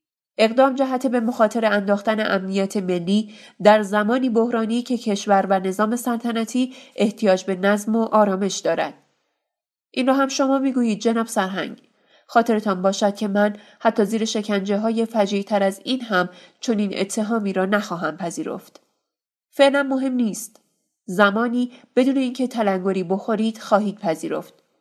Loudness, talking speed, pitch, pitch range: -21 LUFS, 135 wpm, 215 Hz, 200-240 Hz